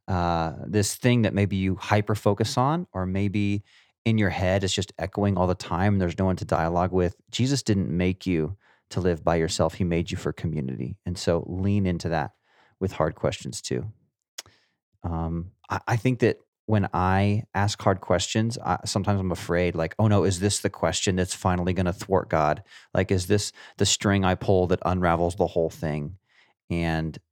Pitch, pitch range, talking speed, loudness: 95 Hz, 85-105 Hz, 195 wpm, -25 LUFS